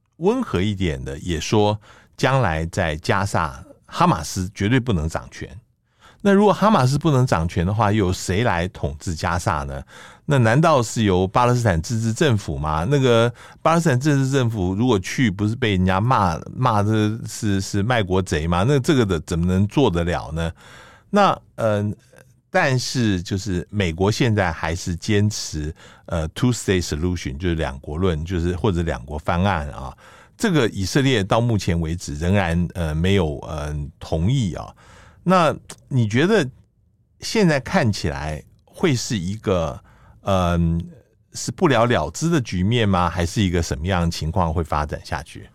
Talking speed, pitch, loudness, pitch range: 260 characters per minute, 95 Hz, -21 LUFS, 85-115 Hz